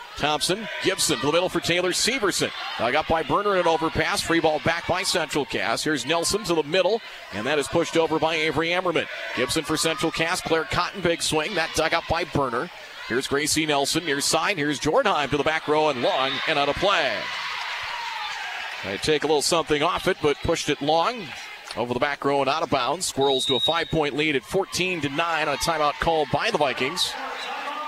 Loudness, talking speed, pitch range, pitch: -23 LUFS, 210 wpm, 145-175 Hz, 160 Hz